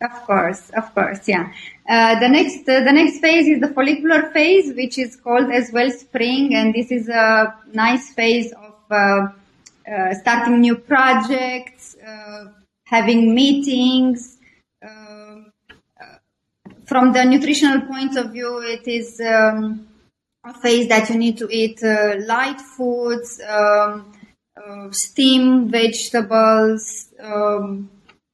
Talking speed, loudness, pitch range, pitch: 130 wpm, -16 LUFS, 215-255 Hz, 235 Hz